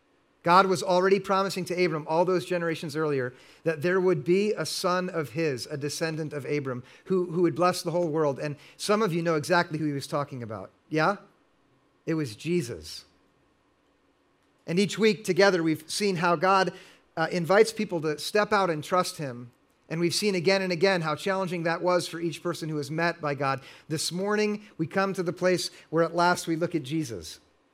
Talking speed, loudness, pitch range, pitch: 200 wpm, -27 LUFS, 155-185 Hz, 170 Hz